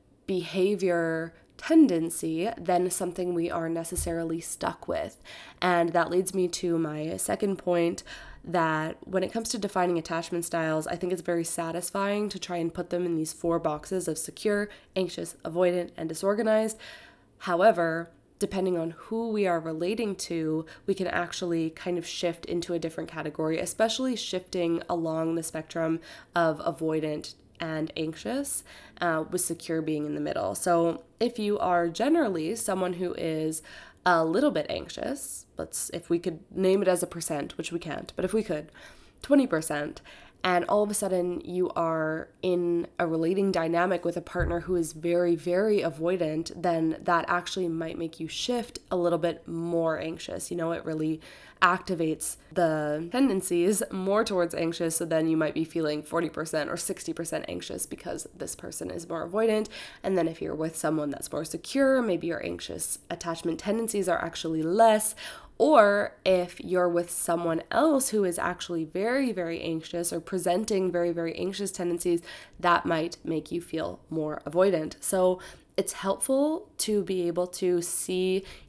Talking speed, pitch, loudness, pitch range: 165 wpm, 175 Hz, -28 LUFS, 165-185 Hz